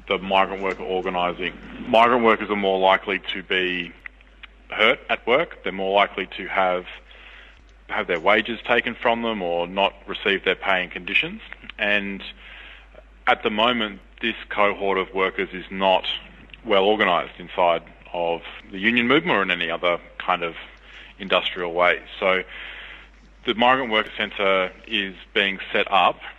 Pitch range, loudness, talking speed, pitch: 90-105 Hz, -22 LUFS, 150 wpm, 95 Hz